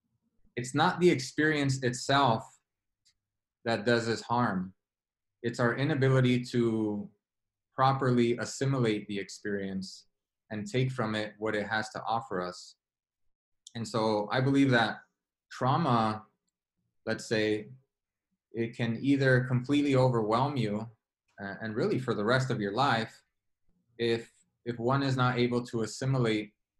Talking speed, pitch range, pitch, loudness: 130 wpm, 105-130 Hz, 115 Hz, -29 LUFS